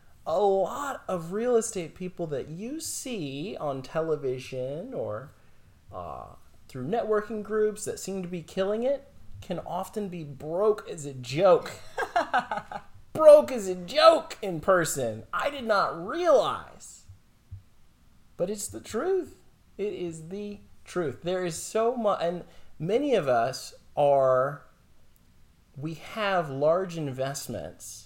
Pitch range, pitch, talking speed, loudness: 140-210 Hz, 180 Hz, 130 wpm, -27 LUFS